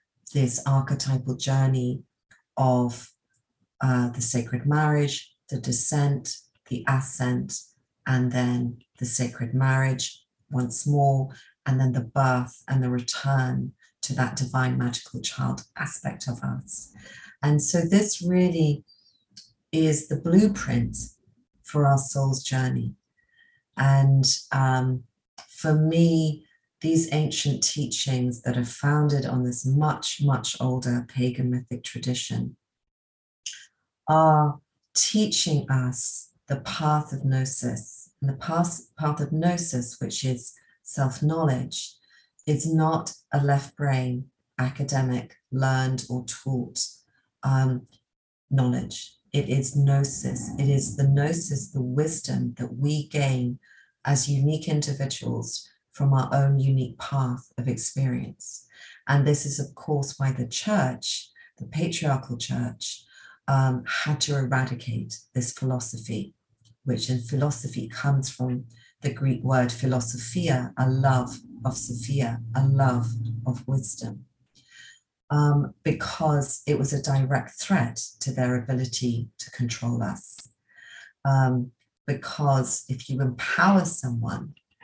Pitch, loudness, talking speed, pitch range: 130 Hz, -25 LUFS, 115 wpm, 125-145 Hz